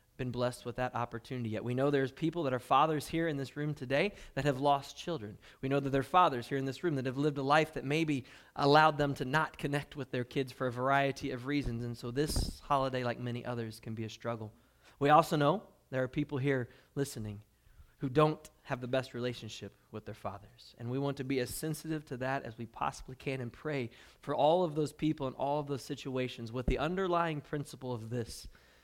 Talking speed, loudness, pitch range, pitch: 230 wpm, -34 LUFS, 120-145 Hz, 135 Hz